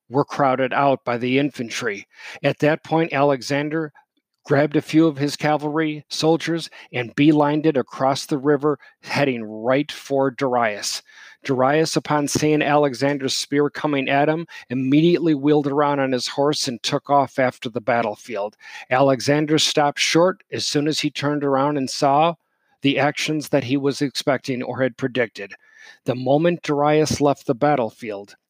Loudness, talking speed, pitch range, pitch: -20 LUFS, 155 wpm, 135-150 Hz, 145 Hz